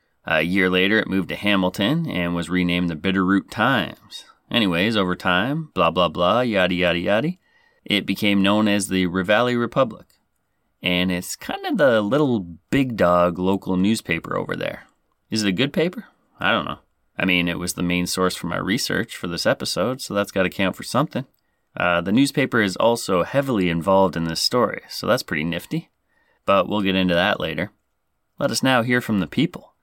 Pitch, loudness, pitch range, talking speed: 95 Hz, -21 LUFS, 90-110 Hz, 190 wpm